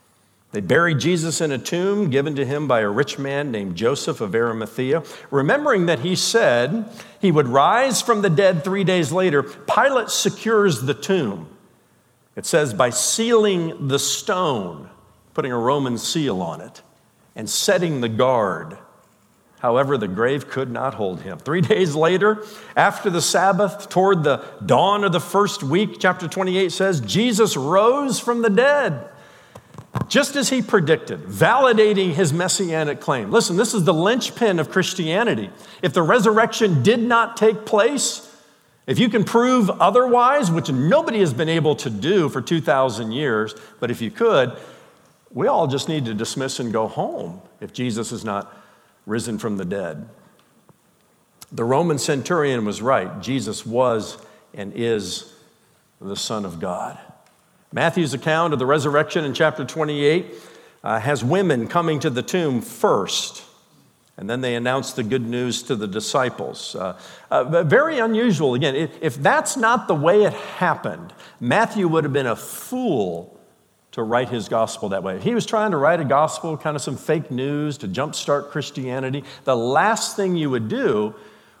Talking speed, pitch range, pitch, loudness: 160 wpm, 135-200 Hz, 165 Hz, -20 LUFS